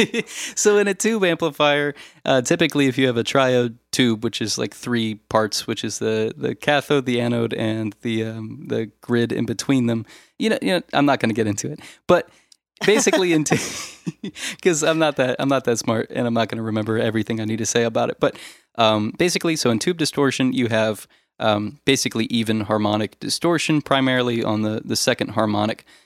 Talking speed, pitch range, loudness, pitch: 205 wpm, 110-145 Hz, -21 LUFS, 120 Hz